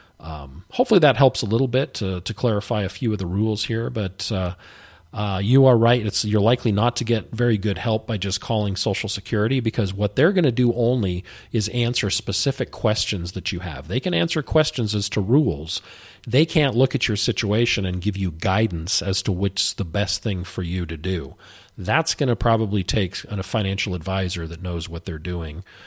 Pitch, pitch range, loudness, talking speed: 105 Hz, 95-115 Hz, -22 LUFS, 210 wpm